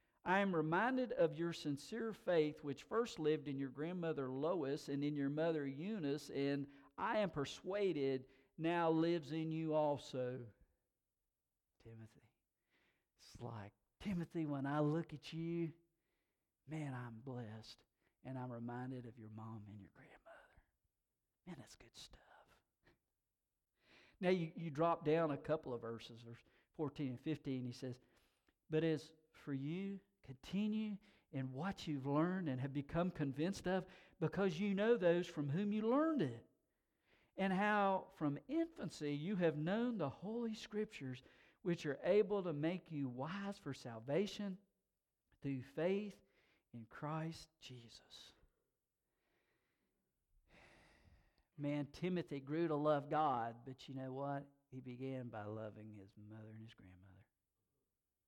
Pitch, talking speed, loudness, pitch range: 150 Hz, 140 wpm, -42 LUFS, 130-175 Hz